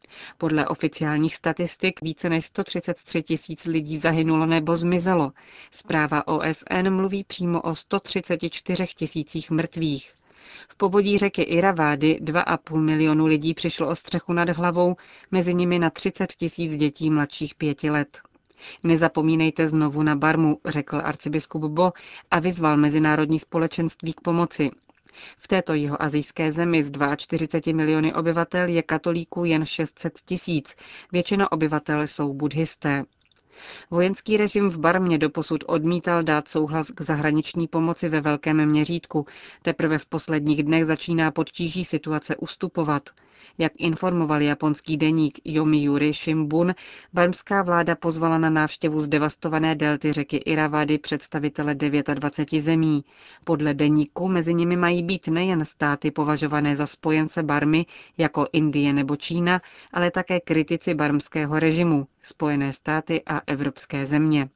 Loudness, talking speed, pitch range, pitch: -23 LUFS, 125 wpm, 150-170 Hz, 160 Hz